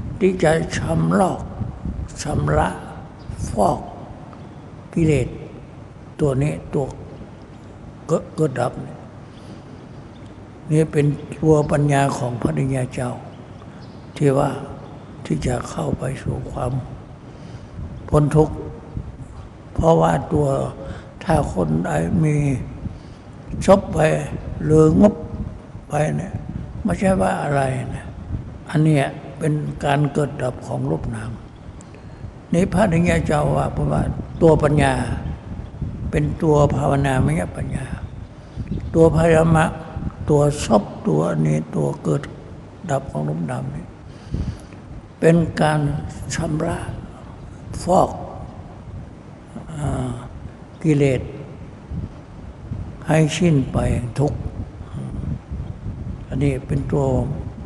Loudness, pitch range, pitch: -20 LUFS, 120-155 Hz, 140 Hz